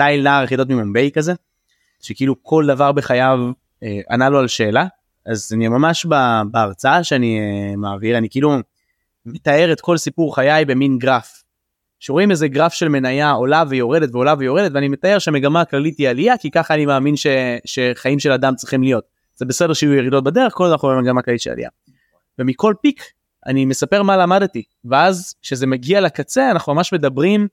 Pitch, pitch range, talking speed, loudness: 140 Hz, 125-160 Hz, 175 wpm, -16 LUFS